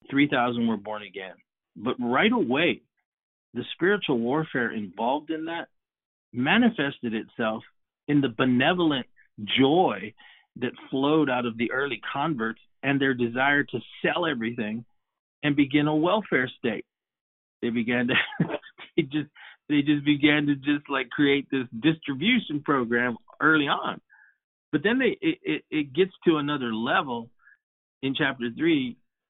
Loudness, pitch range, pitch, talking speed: -25 LUFS, 120-155 Hz, 140 Hz, 140 wpm